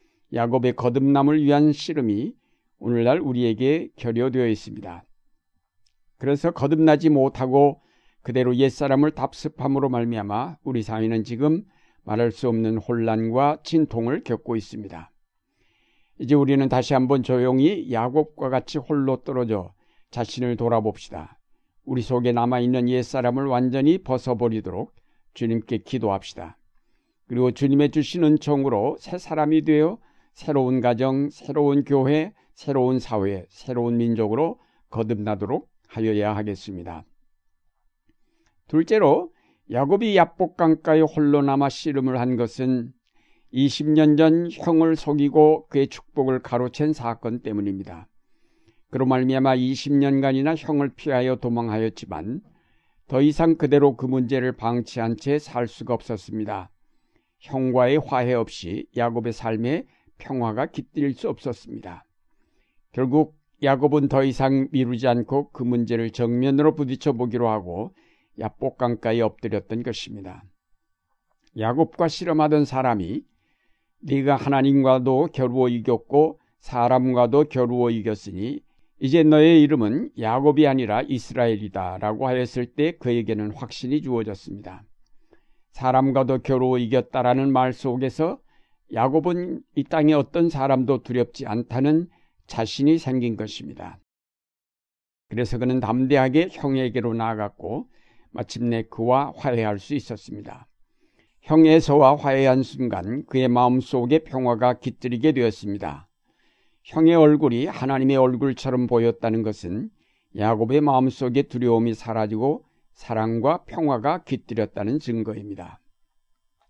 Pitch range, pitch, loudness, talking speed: 115-145 Hz, 130 Hz, -22 LUFS, 290 characters per minute